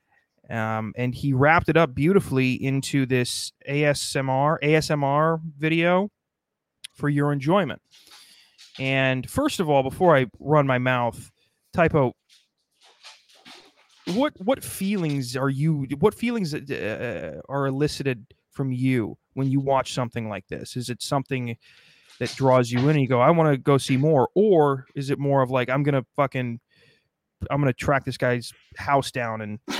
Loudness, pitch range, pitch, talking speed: -23 LUFS, 125-150 Hz, 135 Hz, 155 wpm